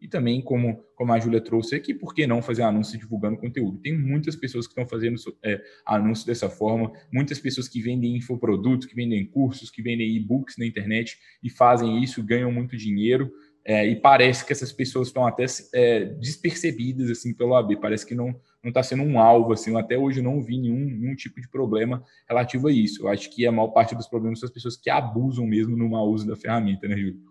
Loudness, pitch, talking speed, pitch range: -24 LUFS, 120 Hz, 215 wpm, 115-130 Hz